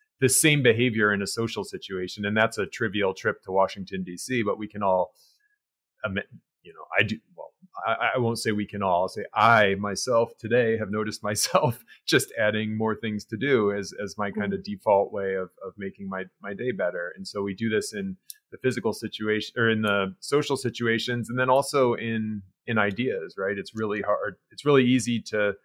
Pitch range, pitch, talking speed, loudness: 100-125 Hz, 110 Hz, 205 wpm, -25 LUFS